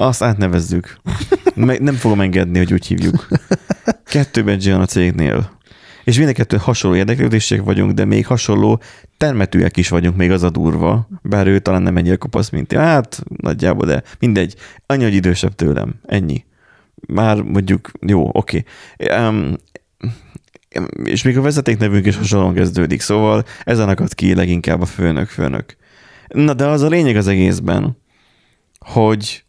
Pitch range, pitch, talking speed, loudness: 90-115 Hz, 105 Hz, 155 wpm, -15 LUFS